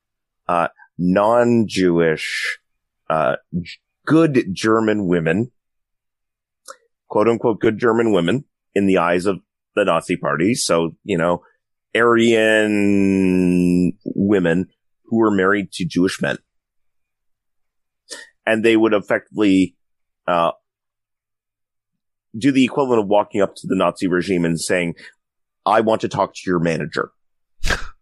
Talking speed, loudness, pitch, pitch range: 115 wpm, -18 LUFS, 100 Hz, 90-110 Hz